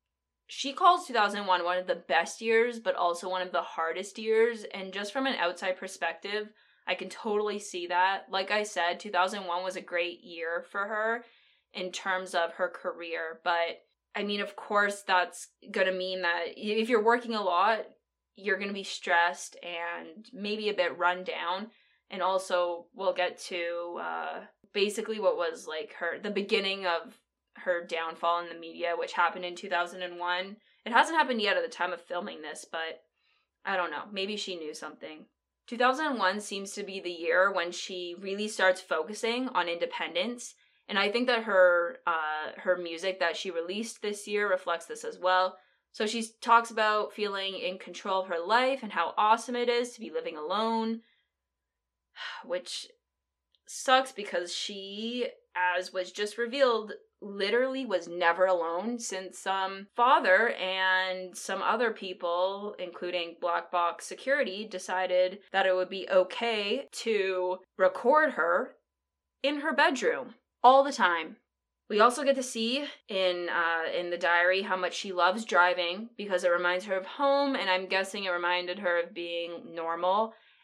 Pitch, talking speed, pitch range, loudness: 190 Hz, 175 wpm, 175-225 Hz, -29 LUFS